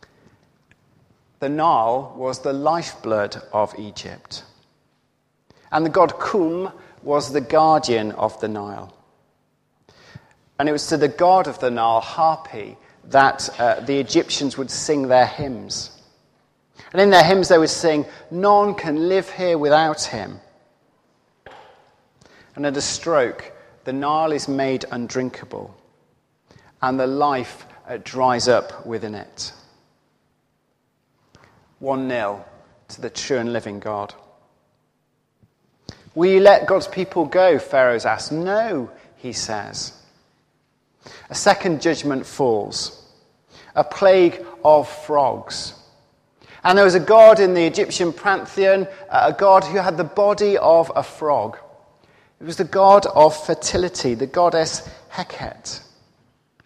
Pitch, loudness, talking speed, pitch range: 150 Hz, -18 LUFS, 125 wpm, 130-180 Hz